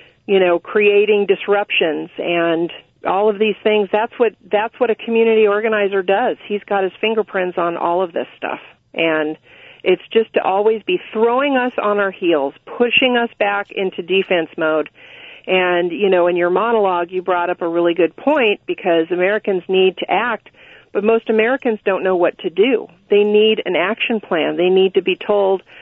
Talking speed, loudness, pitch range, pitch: 185 wpm, -17 LUFS, 180-225 Hz, 200 Hz